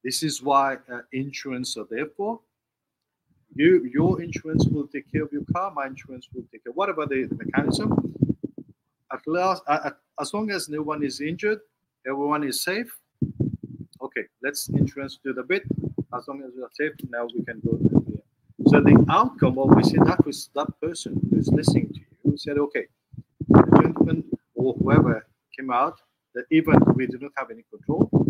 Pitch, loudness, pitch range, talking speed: 145 Hz, -23 LUFS, 130-160 Hz, 180 wpm